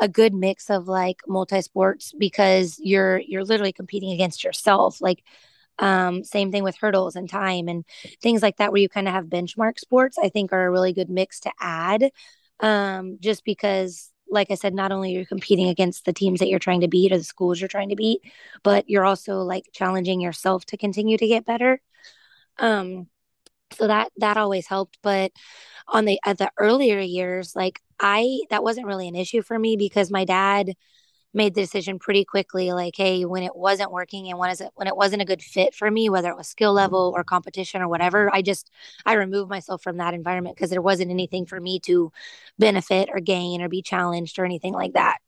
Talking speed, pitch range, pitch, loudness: 210 wpm, 185-205 Hz, 195 Hz, -22 LUFS